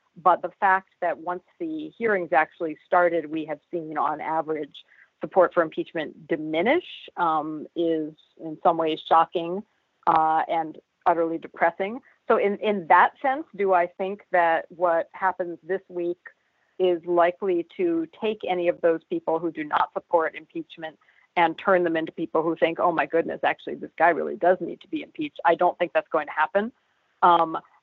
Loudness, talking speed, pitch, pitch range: -24 LUFS, 175 wpm, 175 Hz, 165-190 Hz